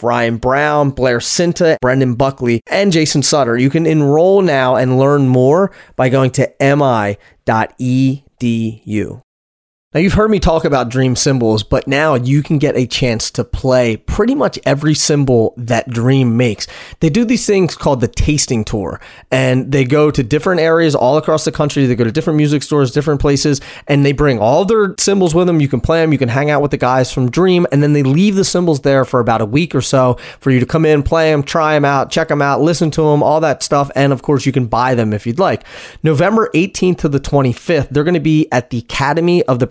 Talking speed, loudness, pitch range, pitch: 220 wpm, -13 LUFS, 125-160 Hz, 140 Hz